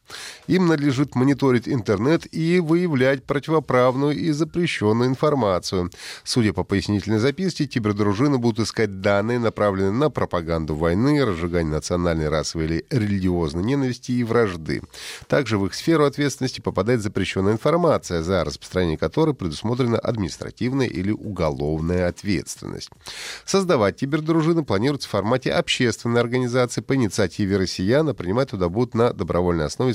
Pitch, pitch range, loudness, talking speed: 115 Hz, 95-140 Hz, -22 LUFS, 125 wpm